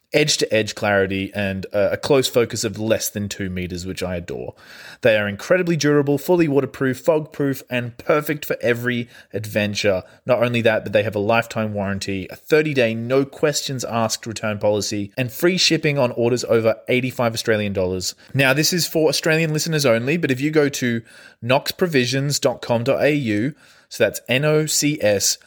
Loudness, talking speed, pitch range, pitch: -20 LUFS, 175 wpm, 105-145 Hz, 120 Hz